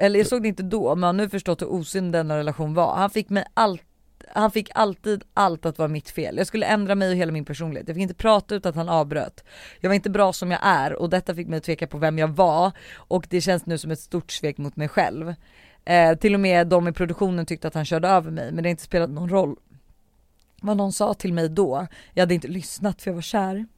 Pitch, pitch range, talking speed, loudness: 180 Hz, 165-200 Hz, 265 wpm, -23 LUFS